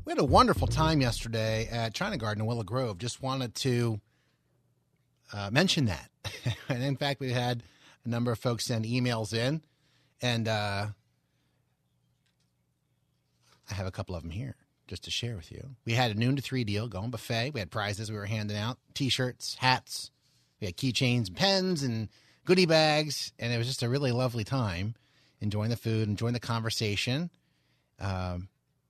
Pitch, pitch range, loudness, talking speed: 115 Hz, 105-130 Hz, -30 LUFS, 180 wpm